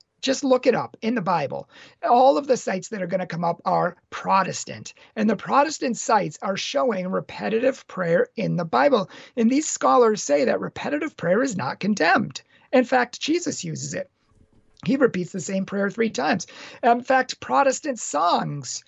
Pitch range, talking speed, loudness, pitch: 185-260 Hz, 180 wpm, -23 LUFS, 230 Hz